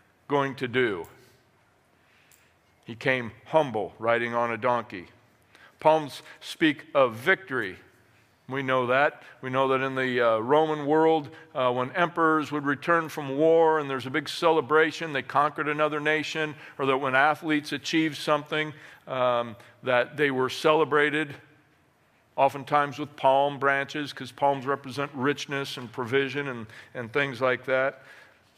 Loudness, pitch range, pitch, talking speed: -26 LUFS, 130-155 Hz, 140 Hz, 140 wpm